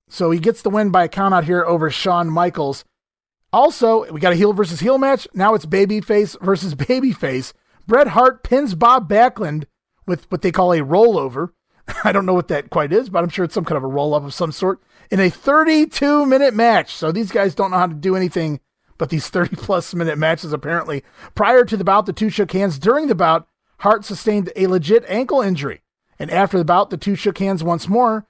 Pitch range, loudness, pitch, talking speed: 170-220 Hz, -17 LUFS, 195 Hz, 220 wpm